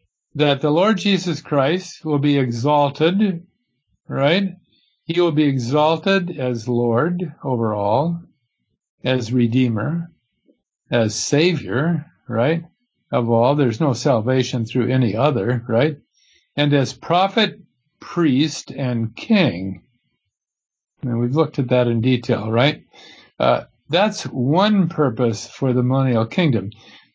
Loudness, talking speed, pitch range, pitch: -19 LUFS, 115 wpm, 120-165 Hz, 140 Hz